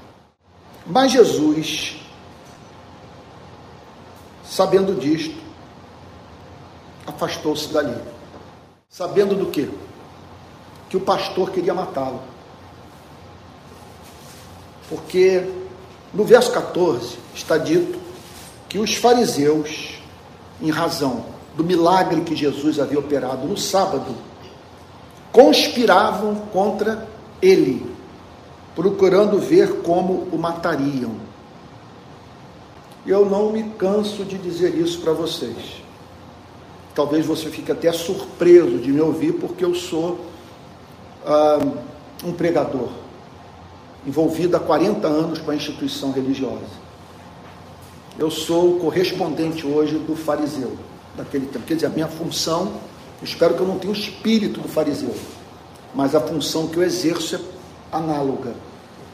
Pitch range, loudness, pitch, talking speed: 145-190 Hz, -19 LUFS, 165 Hz, 105 wpm